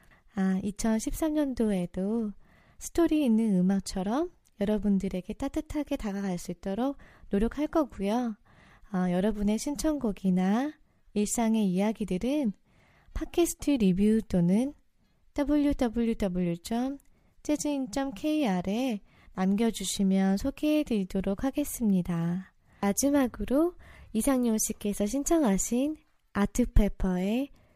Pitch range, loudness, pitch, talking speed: 195-275 Hz, -29 LUFS, 220 Hz, 240 characters per minute